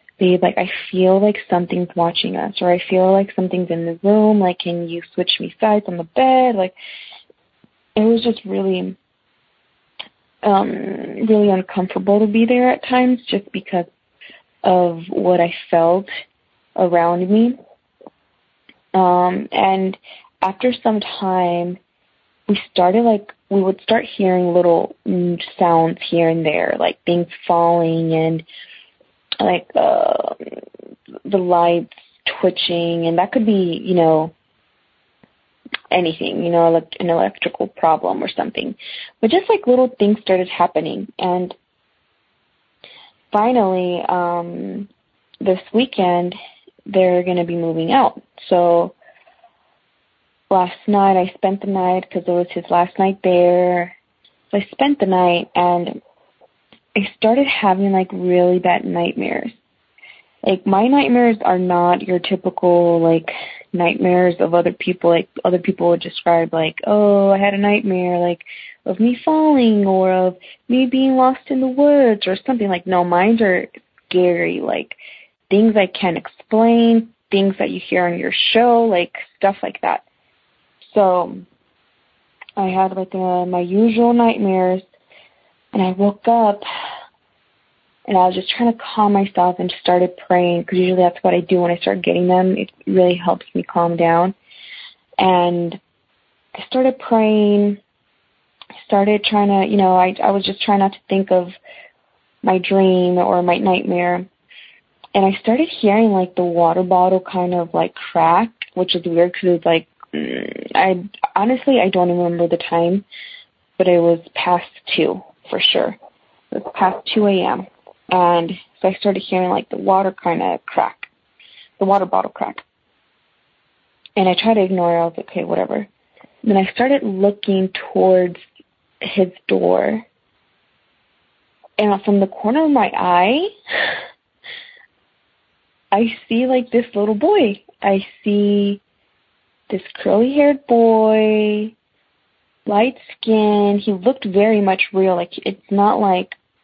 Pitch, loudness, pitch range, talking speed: 190 Hz, -17 LUFS, 180-215 Hz, 145 wpm